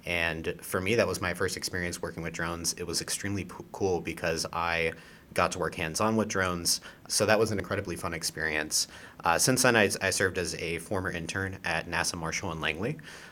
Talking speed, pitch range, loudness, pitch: 210 wpm, 80-95 Hz, -29 LUFS, 85 Hz